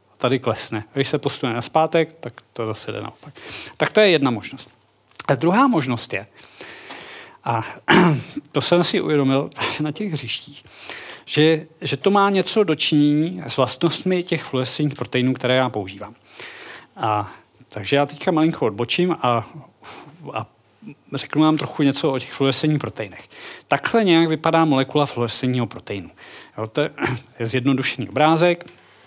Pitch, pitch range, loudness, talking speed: 140 Hz, 125-160 Hz, -20 LUFS, 145 wpm